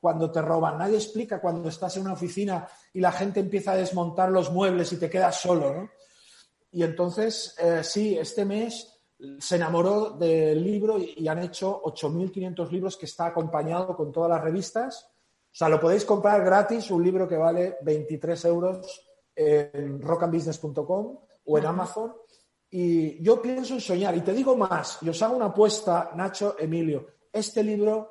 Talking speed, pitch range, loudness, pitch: 175 wpm, 165-205 Hz, -26 LUFS, 180 Hz